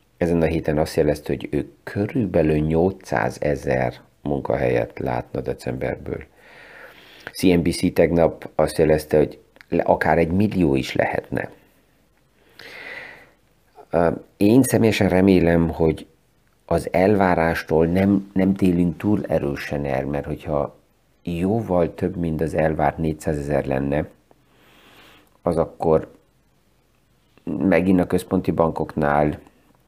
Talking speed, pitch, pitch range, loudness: 100 wpm, 80 Hz, 75-95 Hz, -21 LUFS